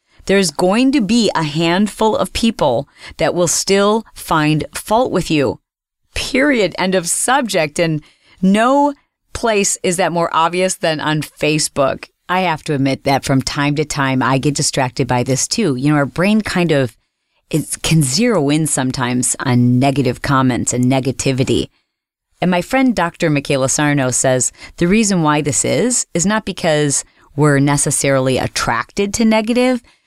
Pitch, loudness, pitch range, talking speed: 155 Hz, -15 LUFS, 135-190 Hz, 160 wpm